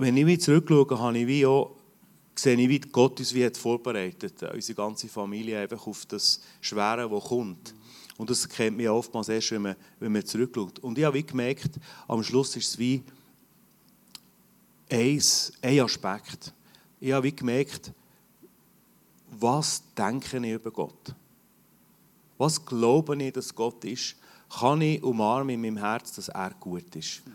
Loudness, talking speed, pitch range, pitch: -27 LUFS, 150 wpm, 115-140 Hz, 125 Hz